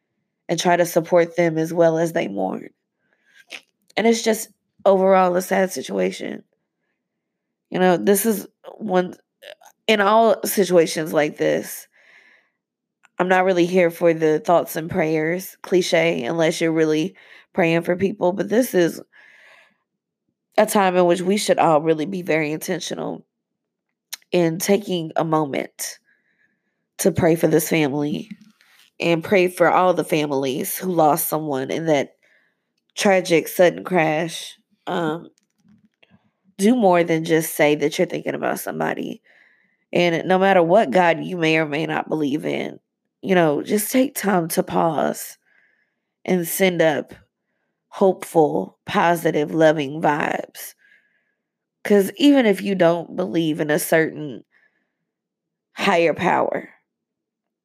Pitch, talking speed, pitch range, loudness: 175 Hz, 135 wpm, 160-195 Hz, -19 LUFS